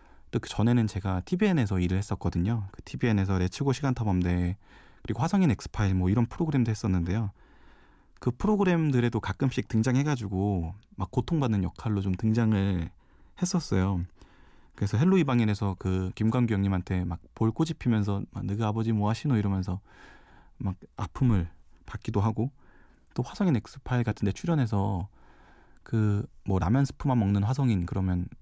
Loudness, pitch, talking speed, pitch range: -28 LUFS, 105 Hz, 350 characters per minute, 95-125 Hz